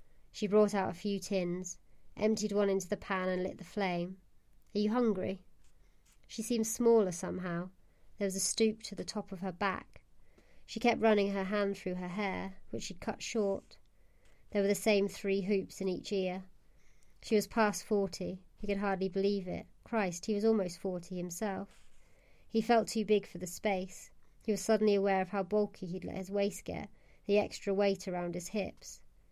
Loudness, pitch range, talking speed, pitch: -34 LUFS, 185-210 Hz, 190 wpm, 195 Hz